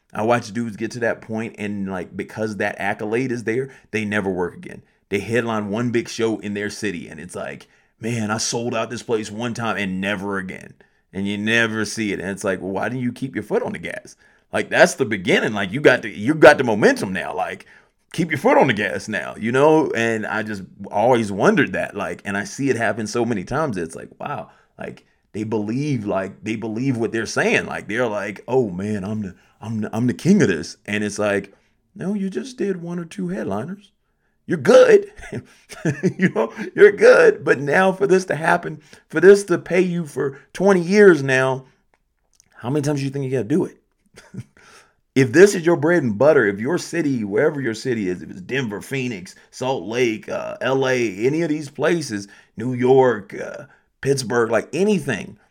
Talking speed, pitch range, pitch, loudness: 210 wpm, 105-150 Hz, 120 Hz, -20 LUFS